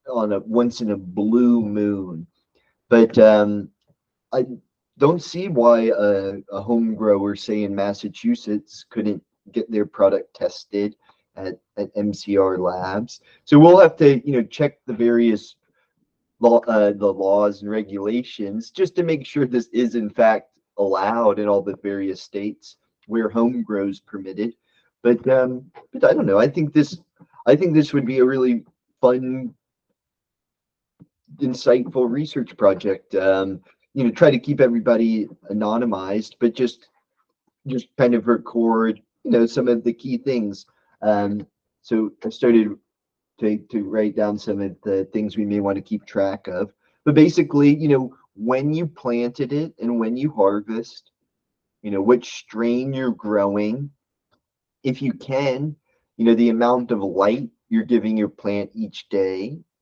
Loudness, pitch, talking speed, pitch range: -20 LUFS, 115 Hz, 155 wpm, 105-130 Hz